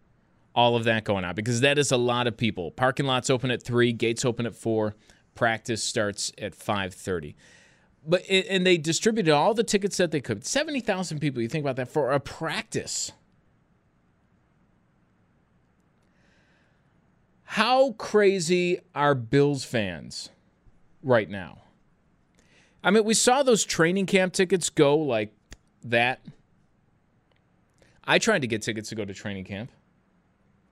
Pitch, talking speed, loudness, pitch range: 135 Hz, 145 wpm, -25 LUFS, 115-185 Hz